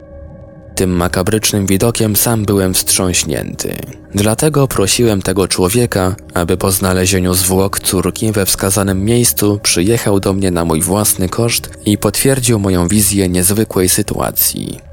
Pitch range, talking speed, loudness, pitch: 90-110 Hz, 125 wpm, -13 LUFS, 100 Hz